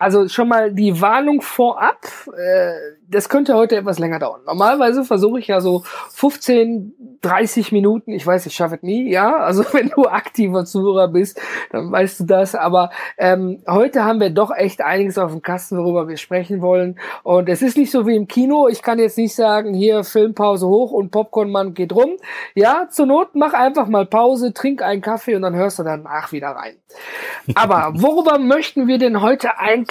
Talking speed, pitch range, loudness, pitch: 195 wpm, 185-250 Hz, -16 LUFS, 210 Hz